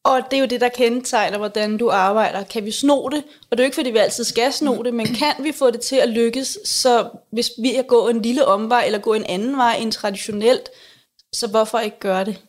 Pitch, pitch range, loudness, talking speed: 235 Hz, 220-260 Hz, -19 LUFS, 255 wpm